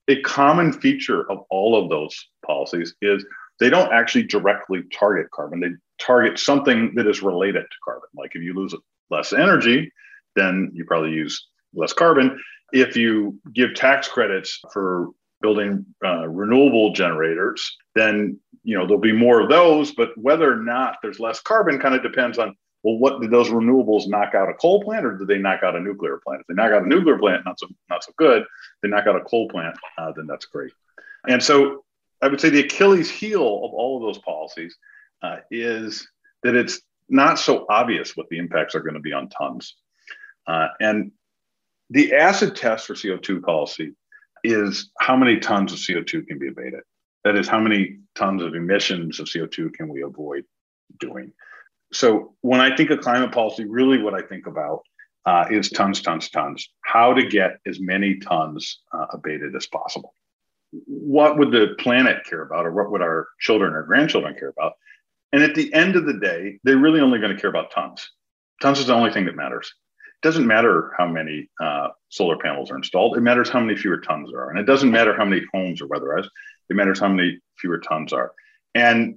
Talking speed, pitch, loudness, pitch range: 200 wpm, 115 Hz, -19 LUFS, 100-150 Hz